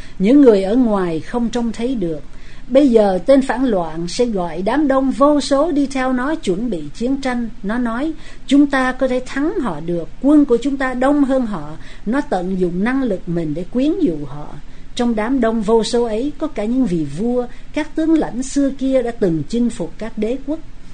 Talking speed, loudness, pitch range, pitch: 215 wpm, -17 LUFS, 195-270 Hz, 245 Hz